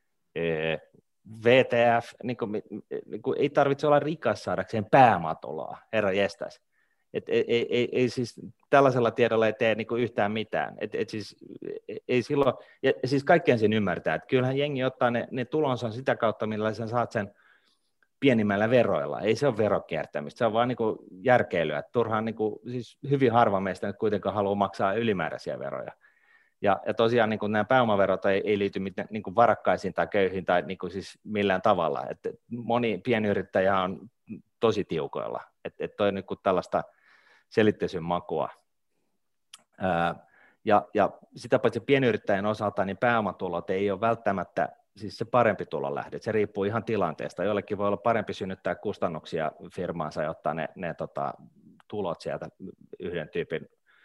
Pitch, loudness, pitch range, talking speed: 115 Hz, -27 LUFS, 105-130 Hz, 155 wpm